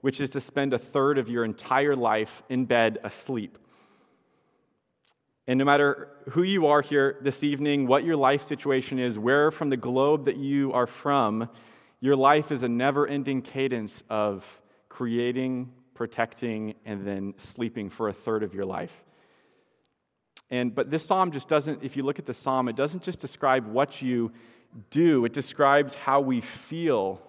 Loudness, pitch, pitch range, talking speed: -26 LUFS, 135 Hz, 120-140 Hz, 170 wpm